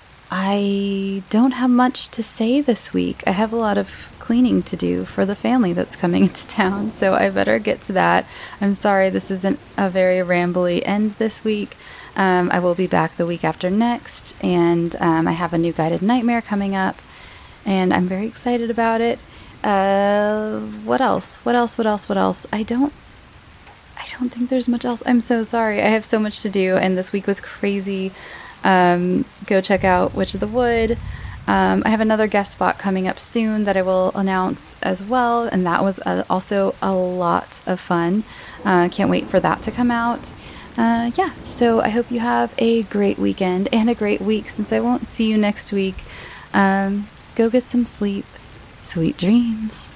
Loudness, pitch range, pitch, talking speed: -19 LUFS, 185-230 Hz, 200 Hz, 195 wpm